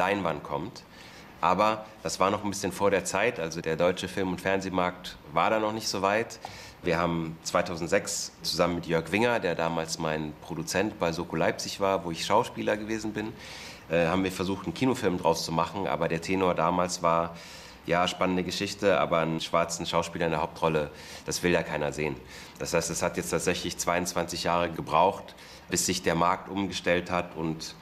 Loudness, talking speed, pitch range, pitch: -28 LUFS, 190 wpm, 80-95 Hz, 85 Hz